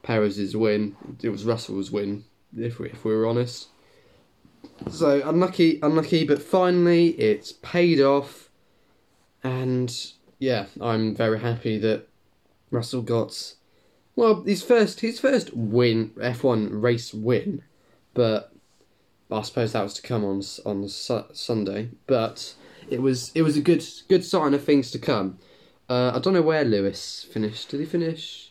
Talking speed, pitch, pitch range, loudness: 150 wpm, 120 Hz, 105-155 Hz, -24 LUFS